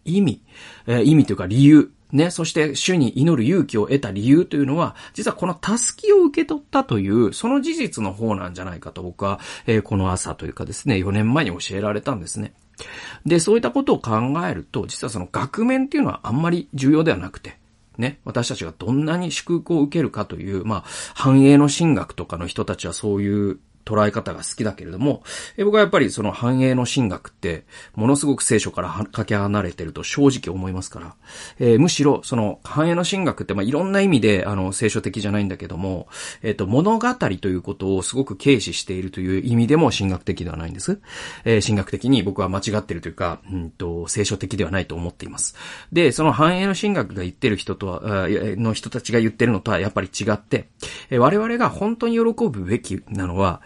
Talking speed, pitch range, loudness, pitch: 405 characters per minute, 95-145 Hz, -20 LUFS, 110 Hz